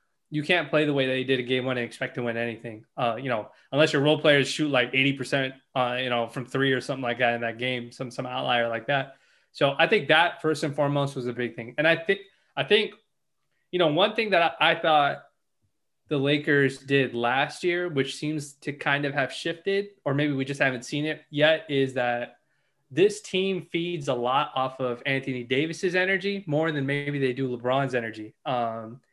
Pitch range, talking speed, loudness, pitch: 125-155 Hz, 220 wpm, -25 LUFS, 135 Hz